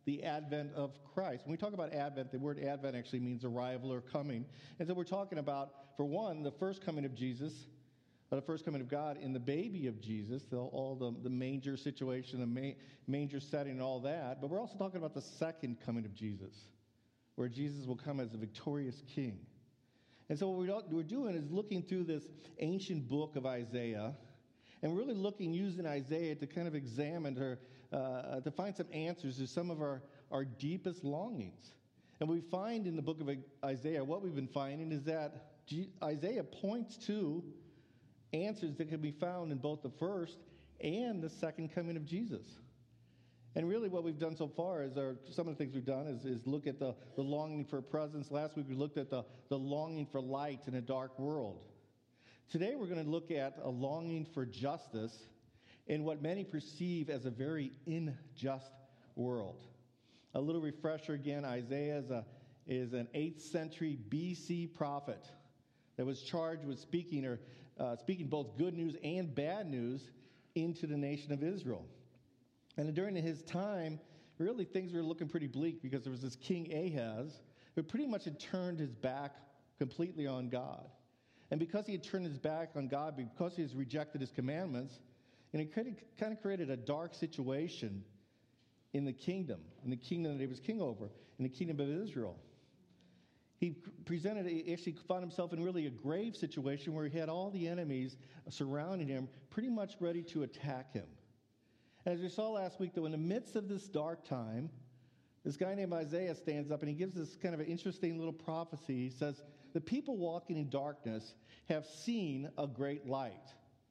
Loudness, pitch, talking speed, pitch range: -41 LUFS, 145 Hz, 190 wpm, 130-165 Hz